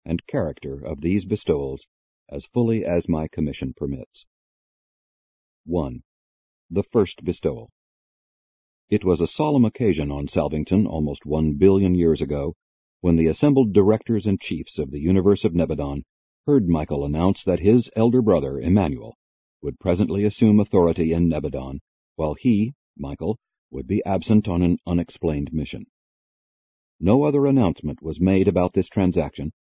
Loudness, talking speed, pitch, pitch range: -22 LUFS, 140 wpm, 85 Hz, 75-105 Hz